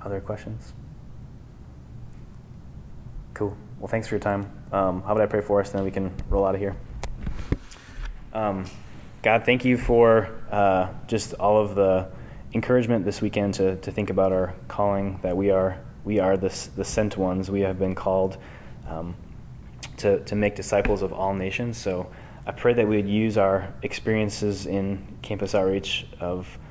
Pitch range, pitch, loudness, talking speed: 95-110 Hz, 100 Hz, -25 LUFS, 170 wpm